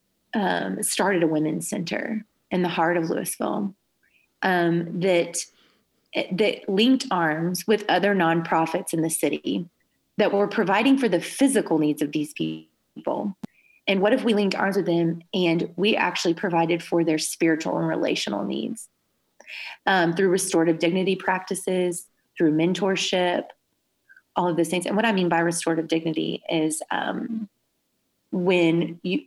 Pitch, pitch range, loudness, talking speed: 180 Hz, 165-200 Hz, -23 LUFS, 145 wpm